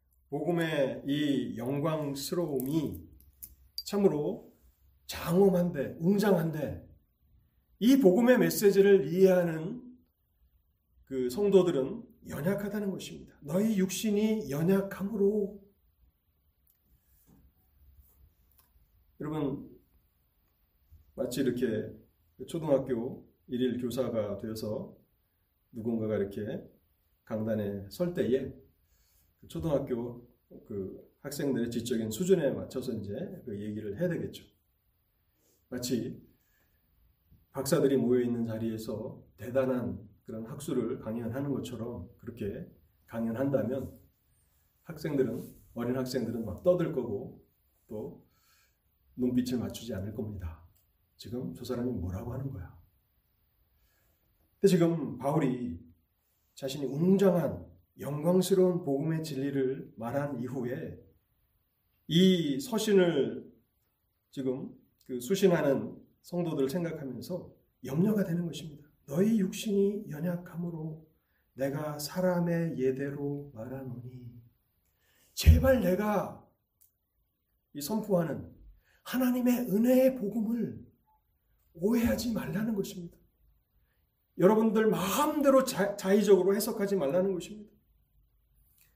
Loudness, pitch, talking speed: -30 LUFS, 130 Hz, 220 characters per minute